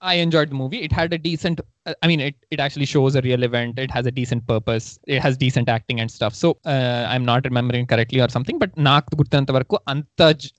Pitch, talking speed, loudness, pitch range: 130 Hz, 230 wpm, -20 LUFS, 120-150 Hz